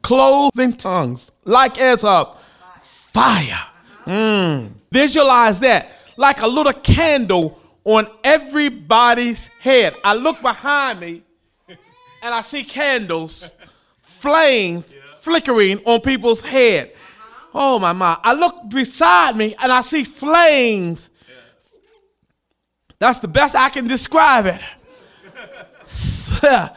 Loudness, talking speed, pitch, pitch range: -15 LUFS, 105 wpm, 250 Hz, 210-285 Hz